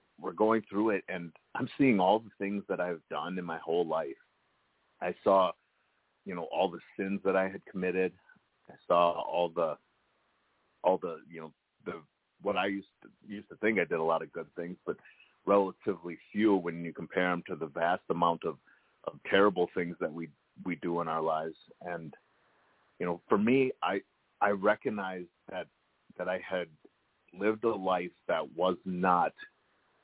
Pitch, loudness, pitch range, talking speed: 95 Hz, -32 LUFS, 85-100 Hz, 180 wpm